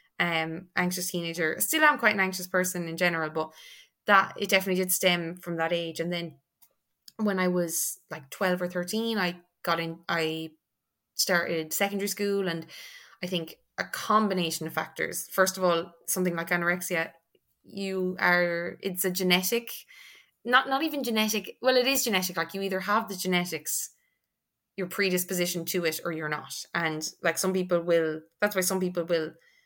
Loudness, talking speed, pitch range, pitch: -27 LUFS, 170 wpm, 165-195 Hz, 180 Hz